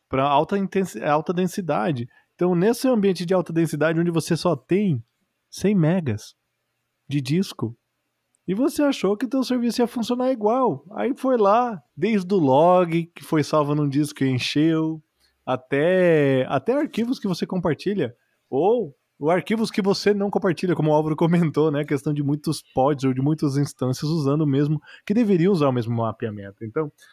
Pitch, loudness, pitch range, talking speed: 165 Hz, -22 LUFS, 145-200 Hz, 170 wpm